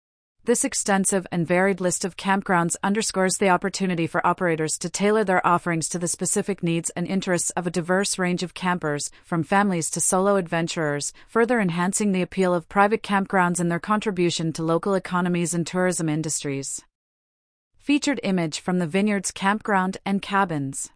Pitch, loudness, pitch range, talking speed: 180 Hz, -23 LUFS, 170-195 Hz, 165 wpm